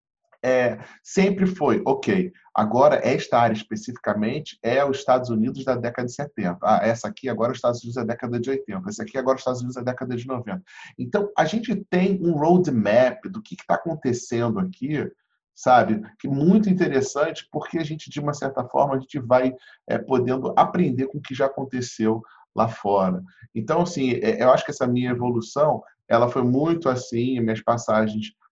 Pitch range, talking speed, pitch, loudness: 120-160 Hz, 185 wpm, 130 Hz, -23 LUFS